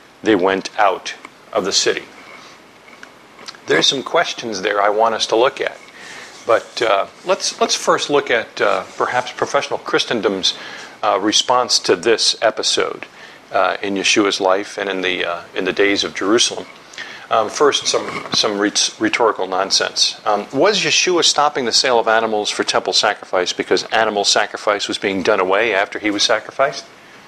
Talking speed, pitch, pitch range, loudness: 165 wpm, 100 Hz, 95-105 Hz, -16 LUFS